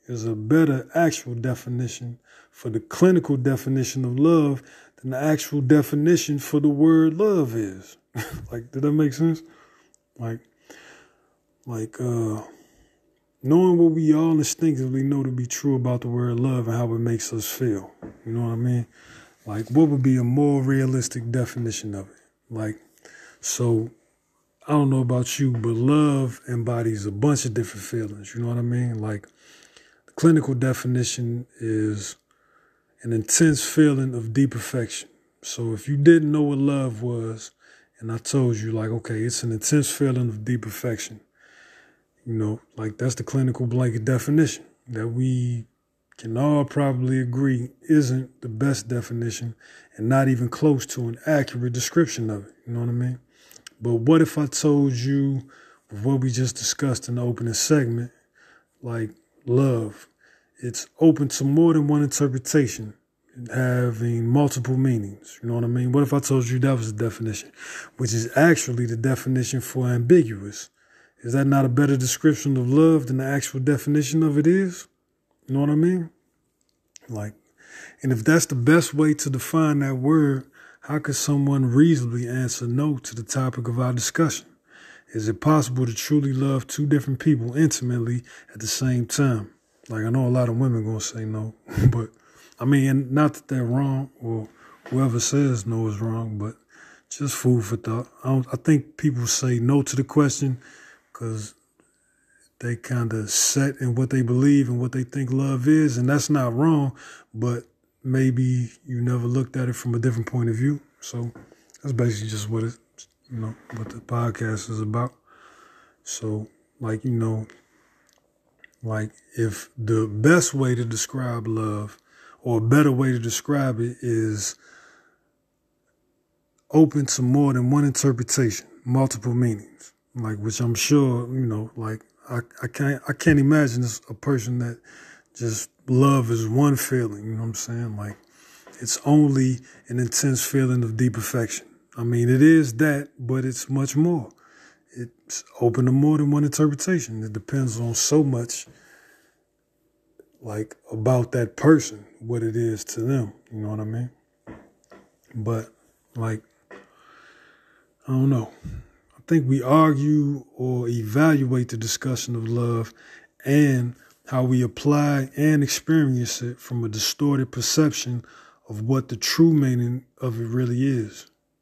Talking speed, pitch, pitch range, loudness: 165 wpm, 125 Hz, 115-140 Hz, -22 LUFS